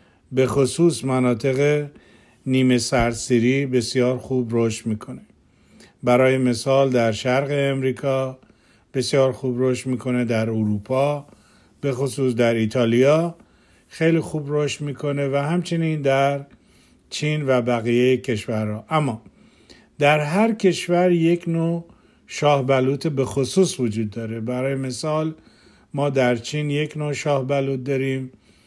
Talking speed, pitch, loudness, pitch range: 120 wpm, 135 Hz, -21 LUFS, 125-145 Hz